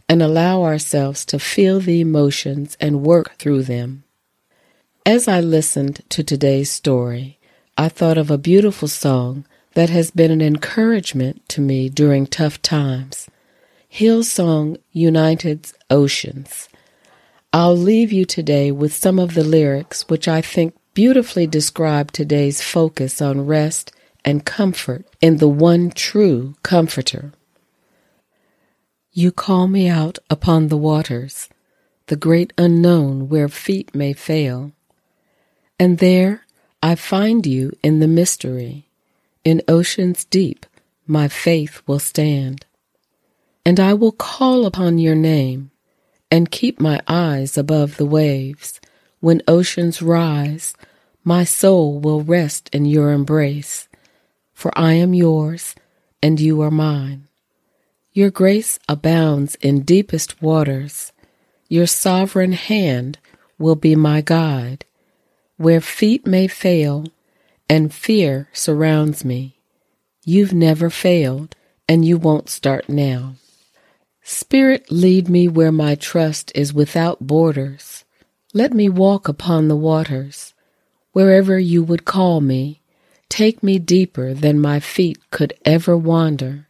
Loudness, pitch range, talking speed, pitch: -16 LUFS, 145-175 Hz, 125 wpm, 160 Hz